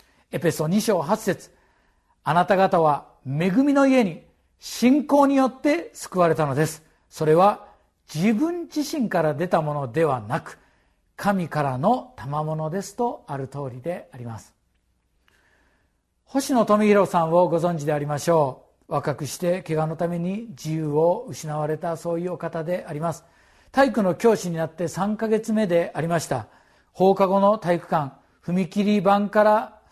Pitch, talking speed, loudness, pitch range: 175 Hz, 280 characters per minute, -23 LUFS, 155-205 Hz